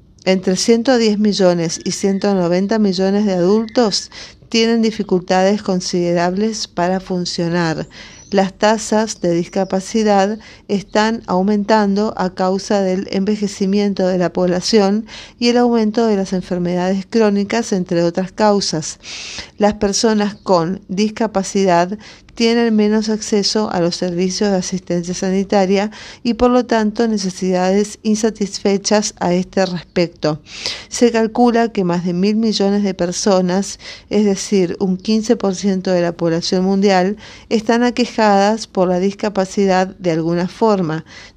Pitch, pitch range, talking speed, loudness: 195 Hz, 185-215 Hz, 120 wpm, -16 LUFS